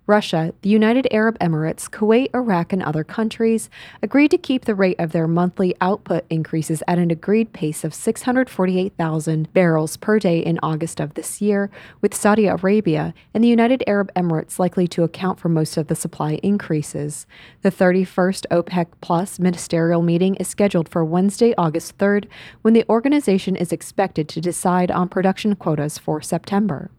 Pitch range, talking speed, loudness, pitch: 165-205 Hz, 165 wpm, -19 LUFS, 180 Hz